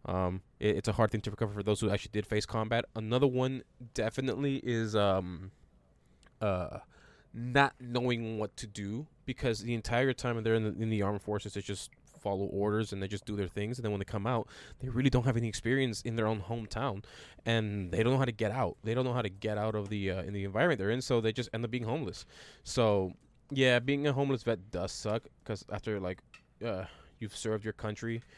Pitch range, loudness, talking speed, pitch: 100-120 Hz, -33 LUFS, 230 wpm, 110 Hz